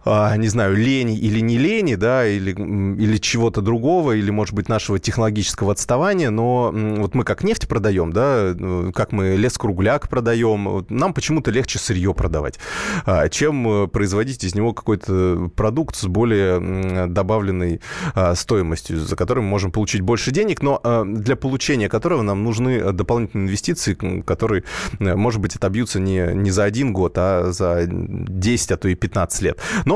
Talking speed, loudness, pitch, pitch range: 155 wpm, -19 LUFS, 105 Hz, 95-115 Hz